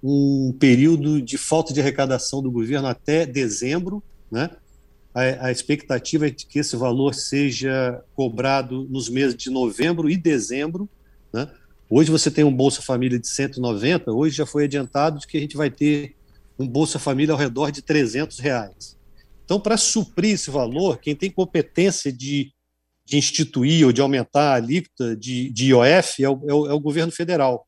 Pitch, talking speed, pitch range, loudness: 140 Hz, 170 wpm, 130-155 Hz, -21 LUFS